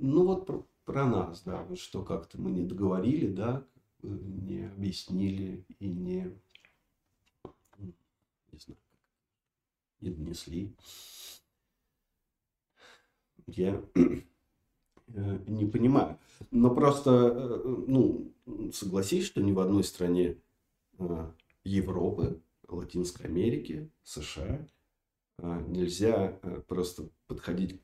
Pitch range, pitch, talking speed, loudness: 90-110 Hz, 95 Hz, 85 wpm, -31 LUFS